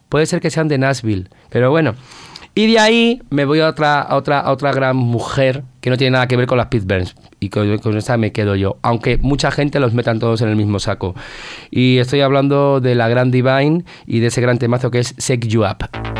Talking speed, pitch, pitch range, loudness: 240 wpm, 125 Hz, 115-140 Hz, -15 LUFS